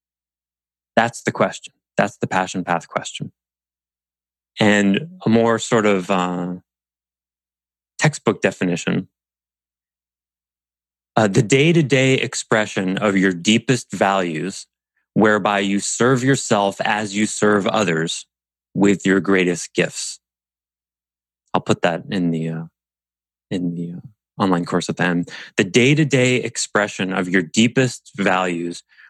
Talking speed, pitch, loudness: 120 wpm, 90 Hz, -19 LUFS